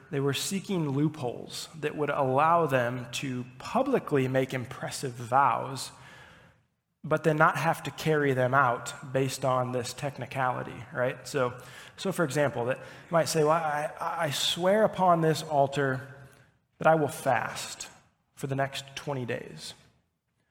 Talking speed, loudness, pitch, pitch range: 145 wpm, -28 LUFS, 140 Hz, 130-160 Hz